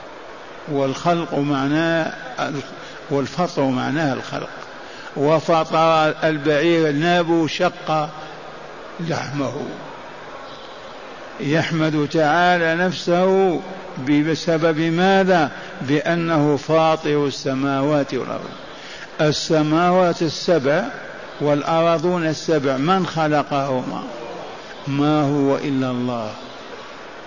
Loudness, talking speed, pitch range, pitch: -19 LUFS, 65 wpm, 145-170 Hz, 155 Hz